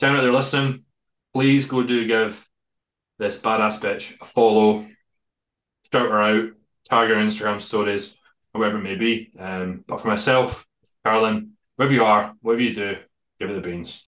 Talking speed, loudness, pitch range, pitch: 160 wpm, -21 LUFS, 105-120 Hz, 110 Hz